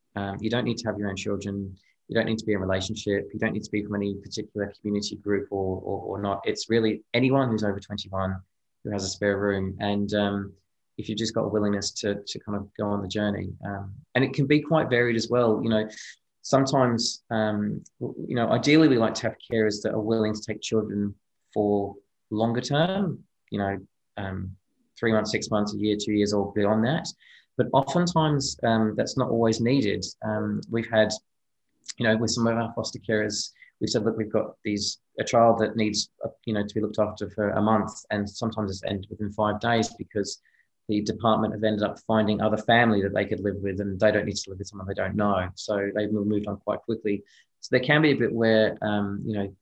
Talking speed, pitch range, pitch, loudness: 225 wpm, 100-115 Hz, 105 Hz, -26 LUFS